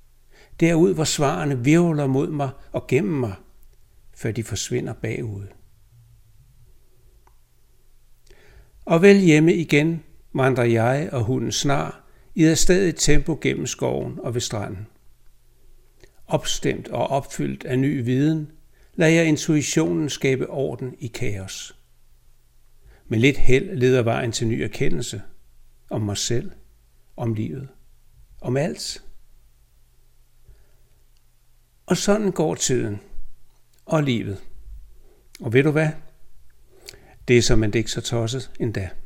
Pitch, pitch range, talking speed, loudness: 125 Hz, 115-150 Hz, 120 wpm, -22 LUFS